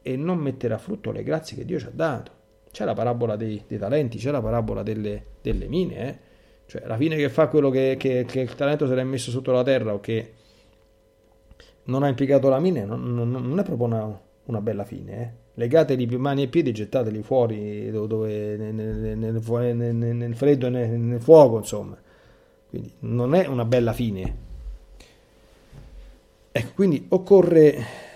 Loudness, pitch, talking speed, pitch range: -23 LUFS, 120 Hz, 185 wpm, 110-135 Hz